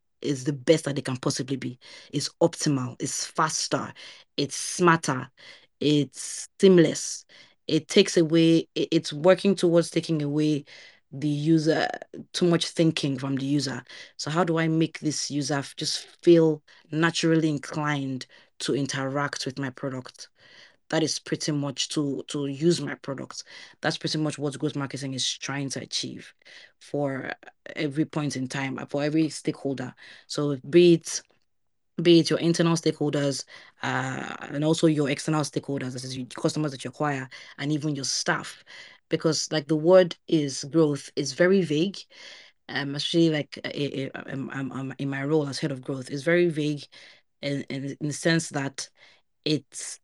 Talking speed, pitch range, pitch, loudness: 160 wpm, 140-160 Hz, 150 Hz, -26 LUFS